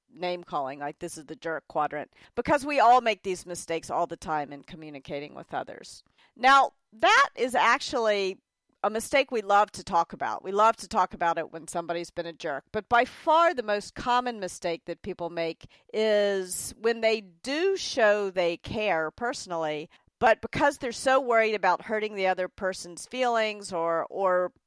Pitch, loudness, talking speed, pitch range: 190 Hz, -27 LUFS, 180 wpm, 170-235 Hz